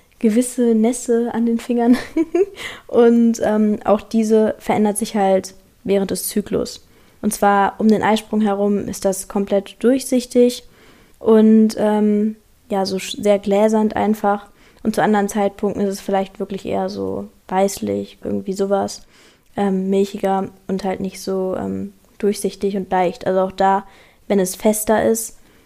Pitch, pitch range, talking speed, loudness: 205 Hz, 195-220 Hz, 145 wpm, -18 LUFS